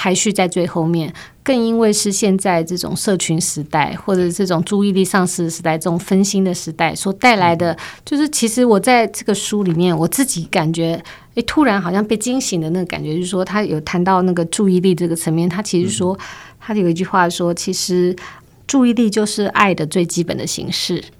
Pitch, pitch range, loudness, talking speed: 185 Hz, 170-210 Hz, -16 LUFS, 315 characters per minute